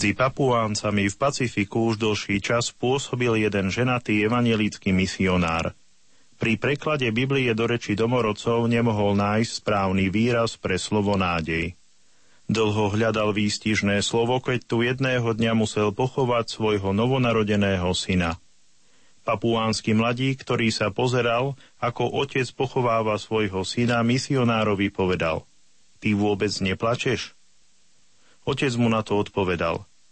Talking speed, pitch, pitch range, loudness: 115 wpm, 110 Hz, 100-120 Hz, -23 LUFS